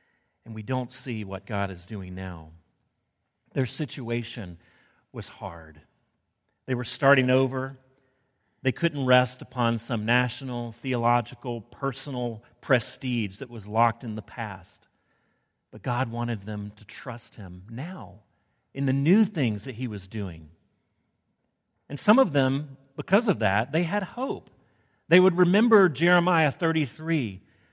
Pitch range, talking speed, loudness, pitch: 110-135 Hz, 135 wpm, -26 LUFS, 125 Hz